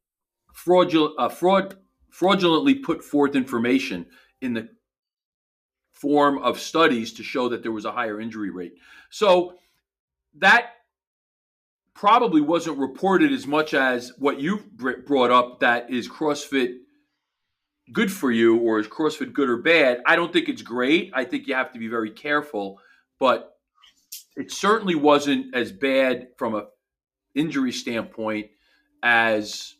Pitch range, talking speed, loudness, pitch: 115-180 Hz, 140 wpm, -22 LUFS, 135 Hz